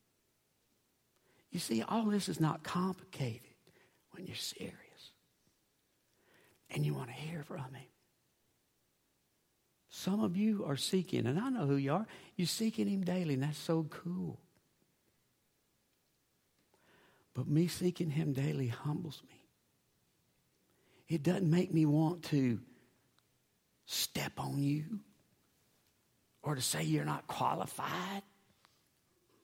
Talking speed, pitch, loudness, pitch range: 120 wpm, 155 Hz, -36 LUFS, 135-180 Hz